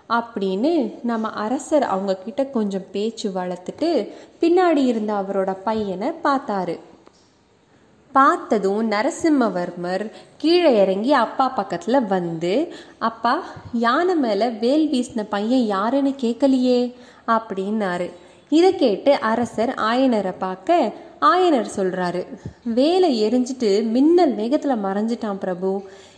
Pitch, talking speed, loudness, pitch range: 230 Hz, 95 wpm, -20 LUFS, 195-275 Hz